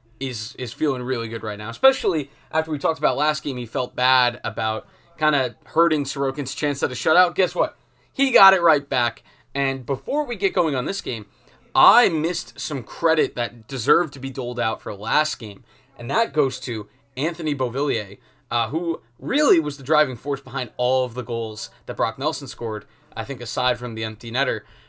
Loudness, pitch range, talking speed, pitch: -22 LUFS, 120-150 Hz, 200 wpm, 135 Hz